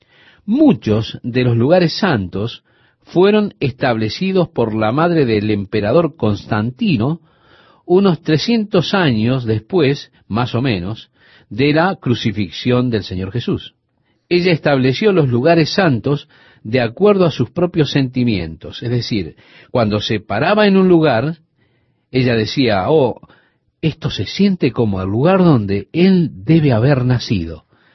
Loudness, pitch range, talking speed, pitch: -15 LUFS, 110-165 Hz, 125 wpm, 130 Hz